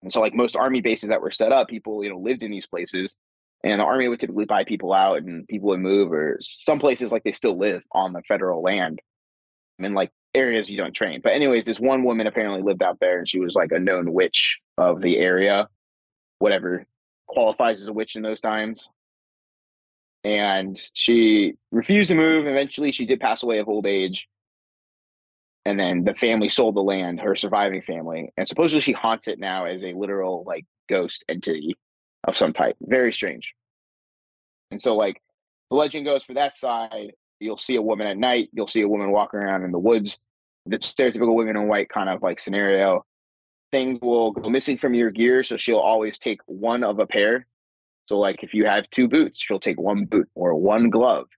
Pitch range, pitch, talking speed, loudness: 95-120 Hz, 110 Hz, 205 wpm, -22 LUFS